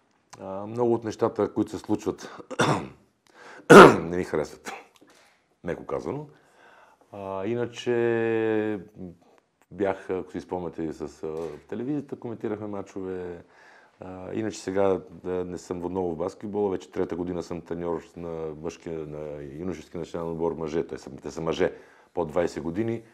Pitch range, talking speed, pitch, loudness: 85-105 Hz, 130 wpm, 90 Hz, -25 LUFS